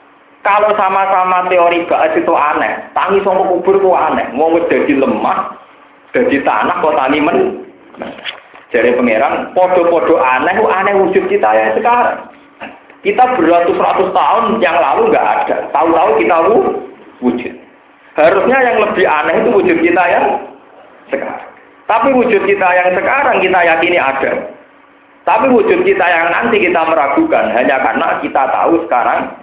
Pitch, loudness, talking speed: 195 Hz, -11 LUFS, 135 wpm